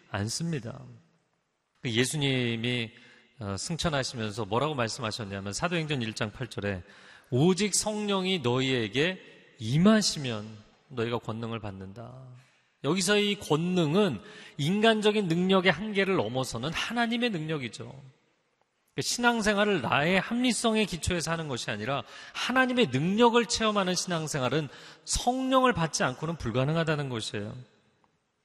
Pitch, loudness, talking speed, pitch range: 150 Hz, -28 LUFS, 290 characters per minute, 120-195 Hz